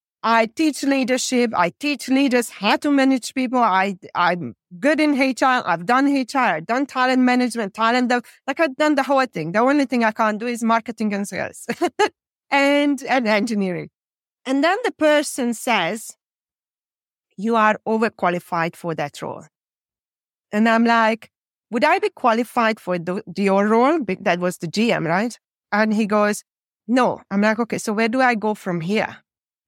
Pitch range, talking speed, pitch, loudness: 210-265 Hz, 170 wpm, 230 Hz, -20 LUFS